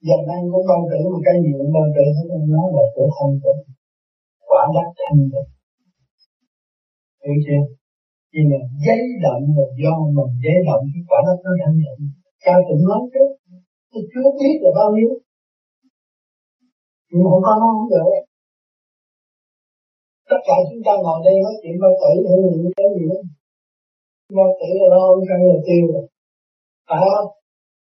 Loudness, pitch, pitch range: -16 LUFS, 180 Hz, 150-205 Hz